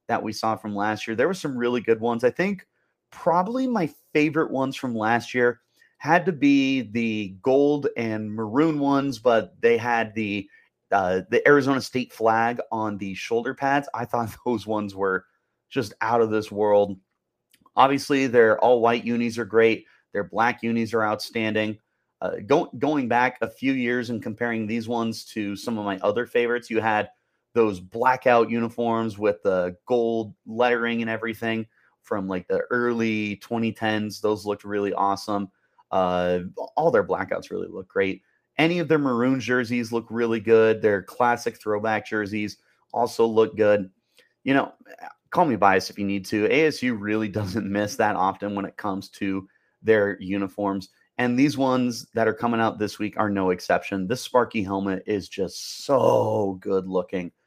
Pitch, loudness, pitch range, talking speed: 115 Hz, -24 LUFS, 105-120 Hz, 170 wpm